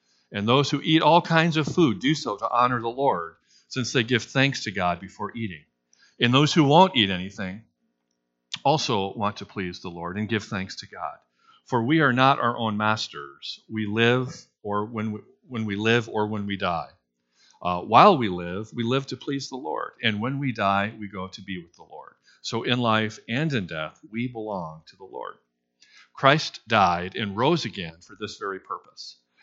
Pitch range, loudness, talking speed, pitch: 95-130 Hz, -24 LUFS, 200 wpm, 110 Hz